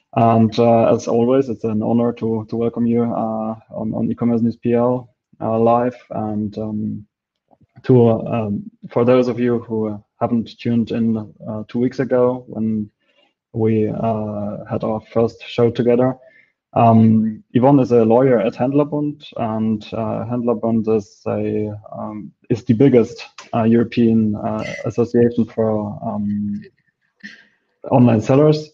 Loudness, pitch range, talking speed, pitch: -18 LUFS, 110-125 Hz, 140 wpm, 115 Hz